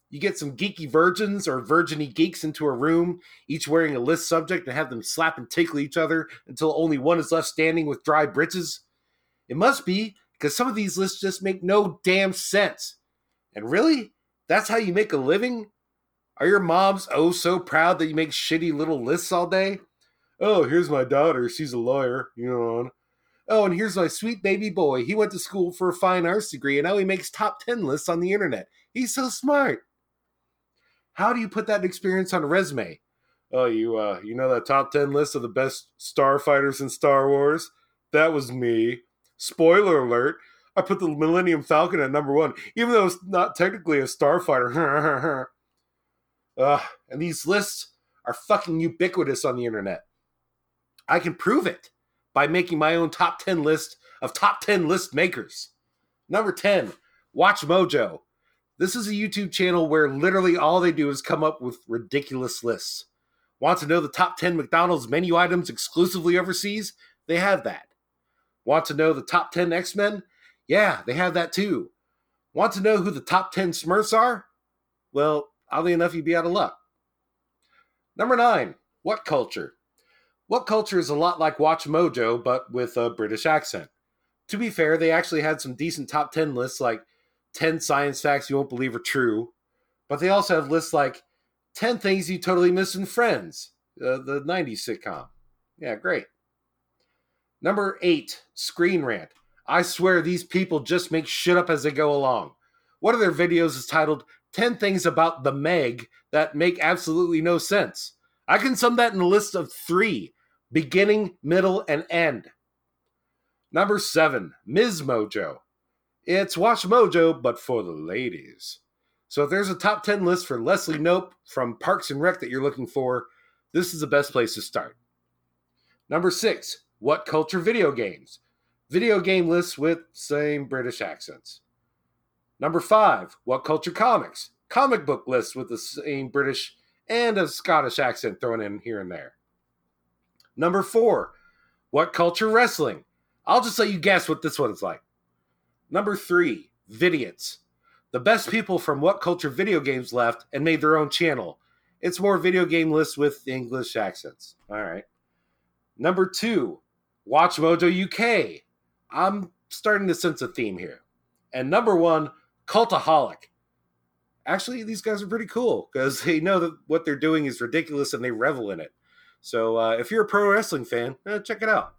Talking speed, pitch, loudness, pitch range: 175 wpm, 170 Hz, -23 LUFS, 145-195 Hz